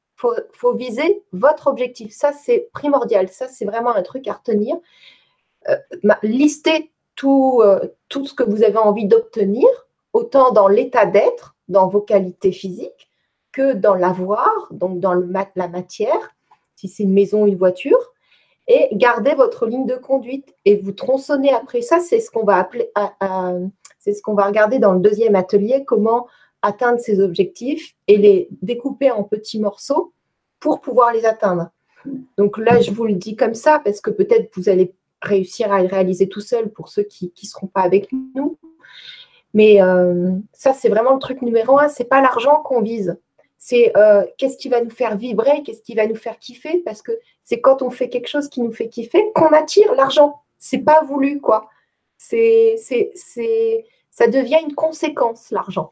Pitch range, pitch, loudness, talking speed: 205-300 Hz, 245 Hz, -17 LUFS, 185 wpm